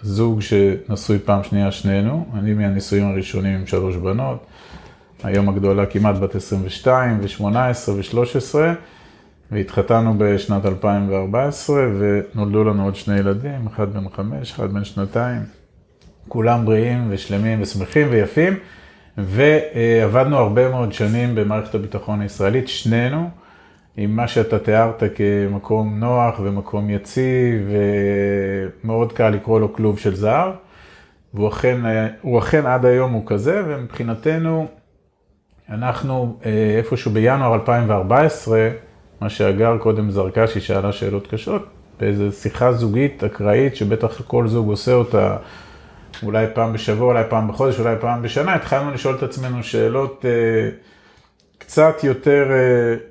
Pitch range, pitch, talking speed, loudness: 100-125 Hz, 110 Hz, 120 wpm, -18 LUFS